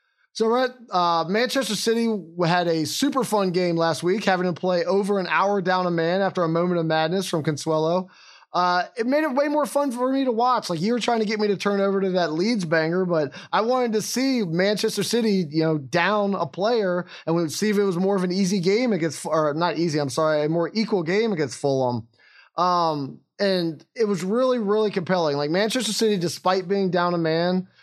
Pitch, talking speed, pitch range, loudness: 185 Hz, 225 wpm, 170-215 Hz, -23 LUFS